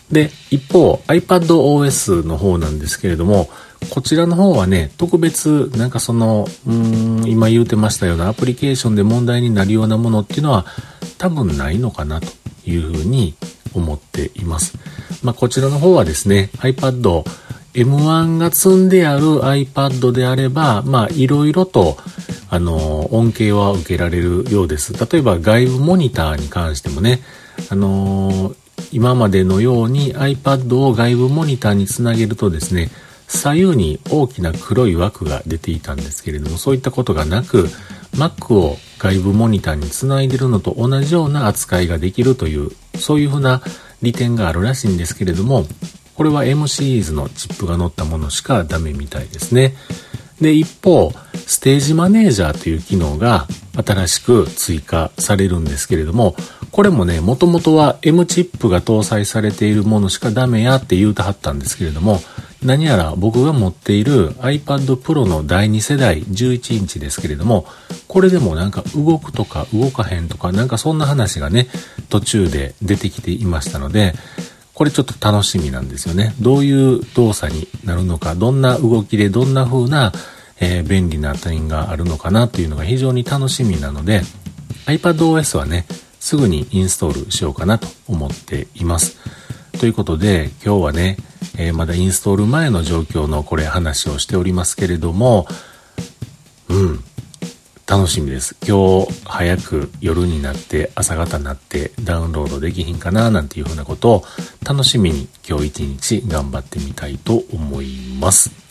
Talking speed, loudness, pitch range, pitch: 355 characters per minute, -16 LUFS, 90-130 Hz, 110 Hz